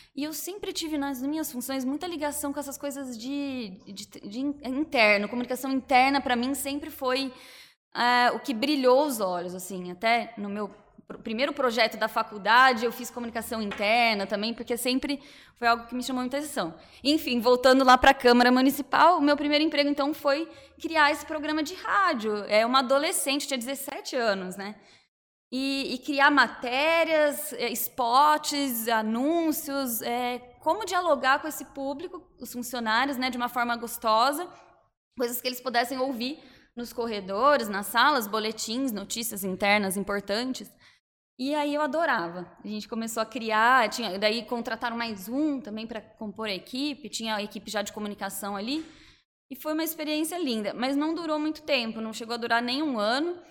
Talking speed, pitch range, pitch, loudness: 165 wpm, 225-285 Hz, 255 Hz, -26 LUFS